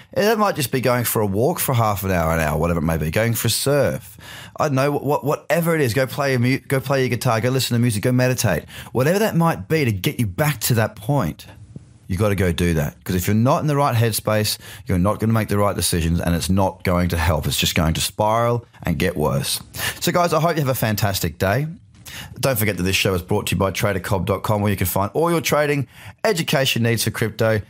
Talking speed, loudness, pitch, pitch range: 260 wpm, -20 LUFS, 110 Hz, 95-135 Hz